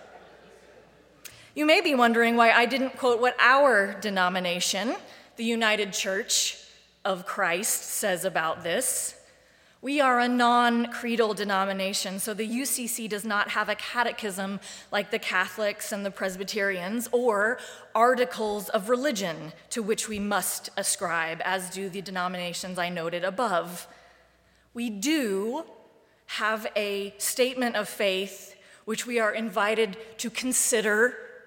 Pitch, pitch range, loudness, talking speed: 215 Hz, 195-240 Hz, -26 LUFS, 130 wpm